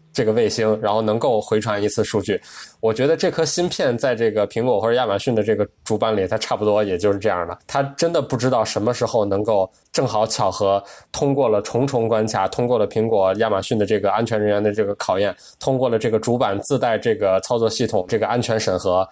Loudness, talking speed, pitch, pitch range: -20 LUFS, 350 characters per minute, 110 Hz, 100-120 Hz